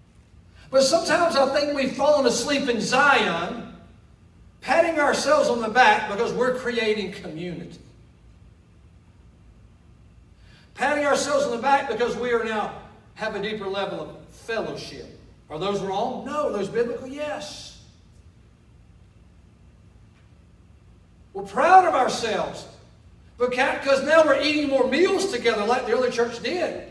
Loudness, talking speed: -22 LUFS, 125 wpm